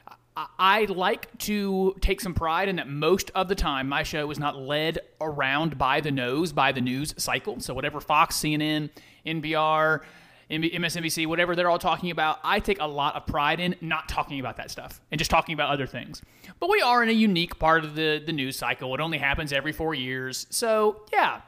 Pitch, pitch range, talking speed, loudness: 155 Hz, 145-175 Hz, 205 wpm, -25 LUFS